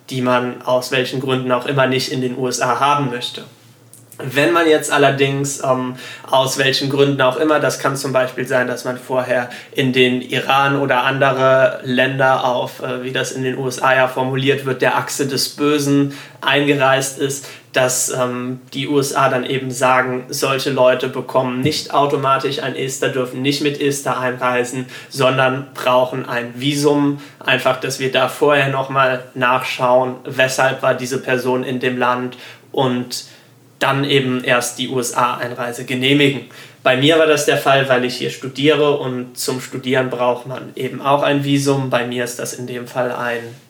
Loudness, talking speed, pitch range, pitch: -17 LUFS, 170 wpm, 125-140 Hz, 130 Hz